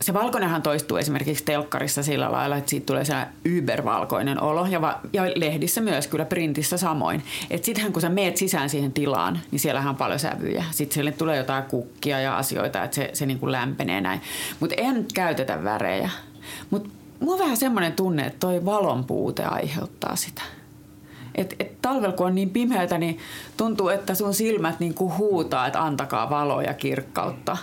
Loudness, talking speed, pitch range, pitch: -25 LUFS, 170 wpm, 145-195 Hz, 165 Hz